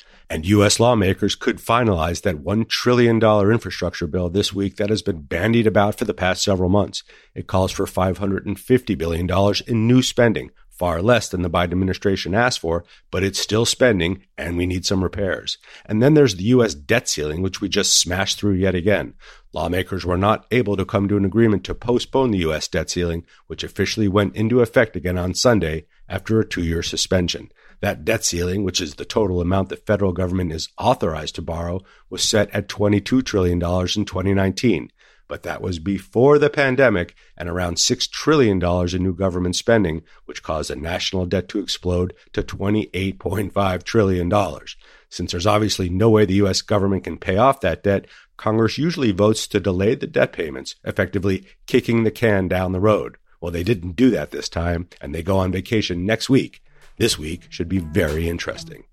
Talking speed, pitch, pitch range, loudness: 185 wpm, 95 Hz, 90-110 Hz, -20 LUFS